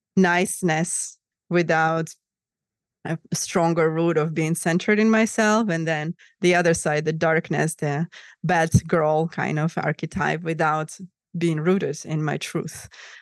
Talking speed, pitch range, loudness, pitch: 130 wpm, 155-175 Hz, -22 LUFS, 165 Hz